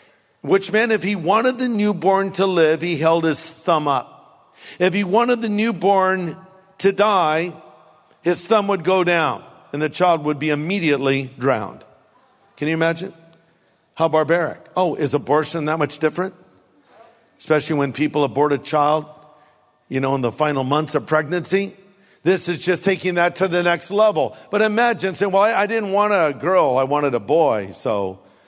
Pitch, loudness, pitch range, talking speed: 170 Hz, -19 LUFS, 150-195 Hz, 170 wpm